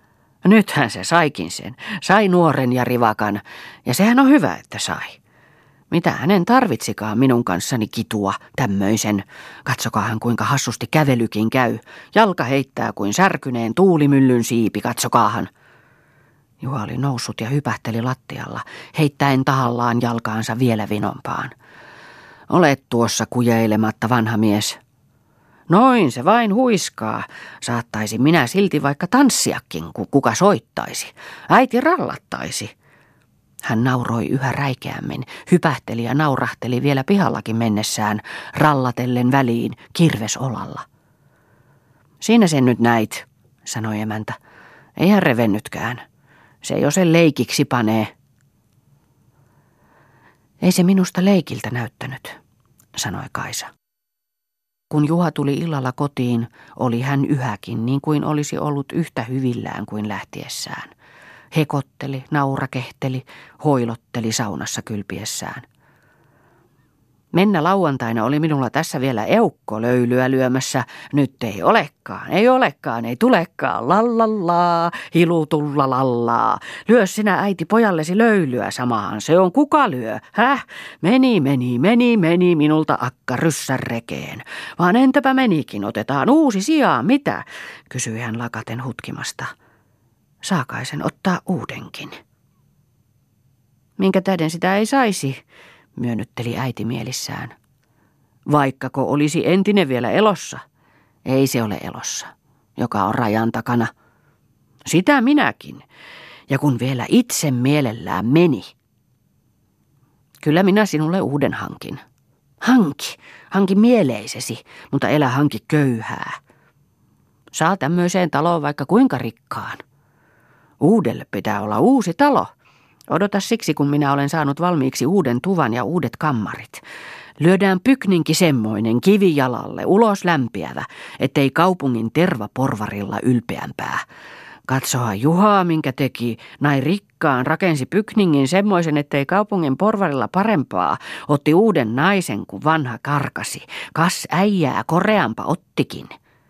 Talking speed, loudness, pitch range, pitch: 110 wpm, -18 LUFS, 120-175 Hz, 140 Hz